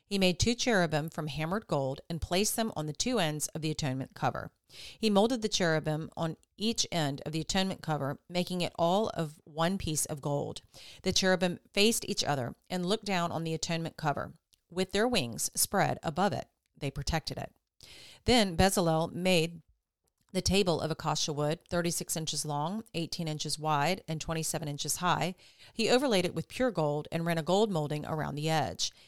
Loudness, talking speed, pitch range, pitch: -31 LUFS, 185 wpm, 155-185 Hz, 165 Hz